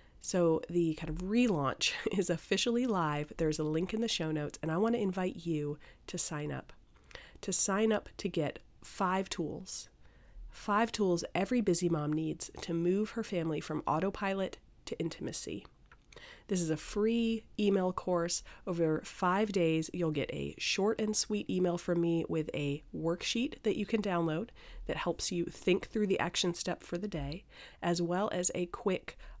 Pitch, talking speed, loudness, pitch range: 180 Hz, 175 wpm, -33 LUFS, 160-205 Hz